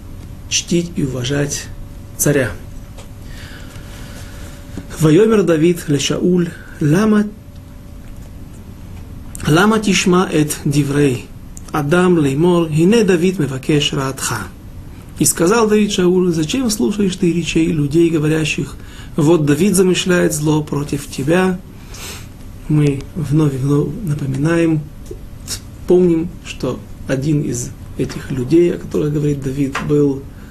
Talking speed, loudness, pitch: 95 wpm, -16 LUFS, 145 Hz